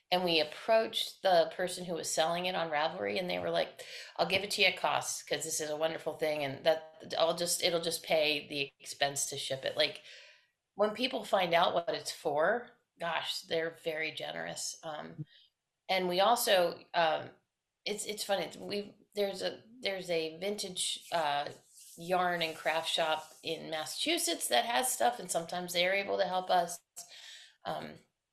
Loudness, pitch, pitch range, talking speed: -32 LUFS, 170 Hz, 155-190 Hz, 175 wpm